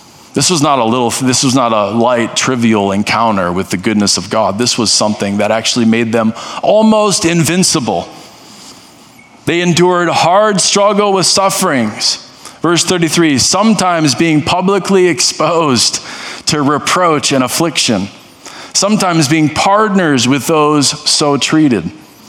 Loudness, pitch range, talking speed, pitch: -11 LUFS, 120-185 Hz, 130 wpm, 160 Hz